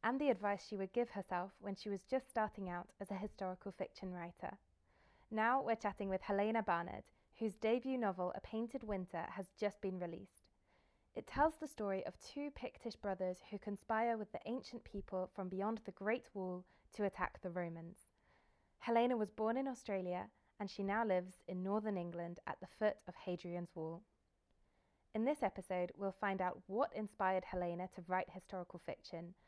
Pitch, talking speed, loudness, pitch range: 200 Hz, 180 wpm, -42 LUFS, 185-220 Hz